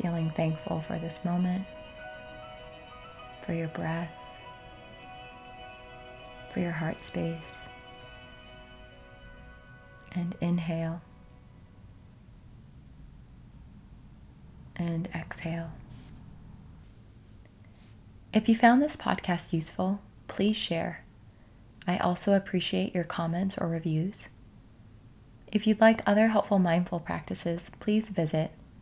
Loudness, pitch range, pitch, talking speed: -29 LUFS, 115-175 Hz, 155 Hz, 85 wpm